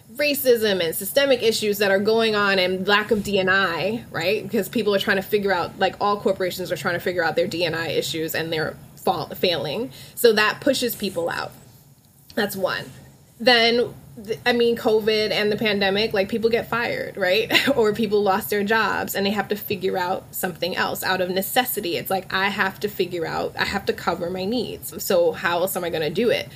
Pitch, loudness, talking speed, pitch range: 205 Hz, -22 LUFS, 210 wpm, 185-225 Hz